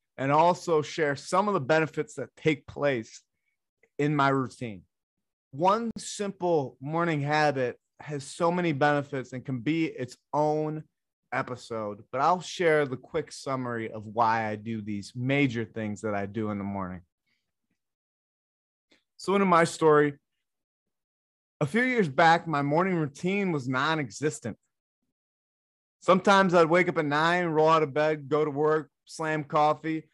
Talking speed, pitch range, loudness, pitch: 150 wpm, 125-165 Hz, -27 LUFS, 150 Hz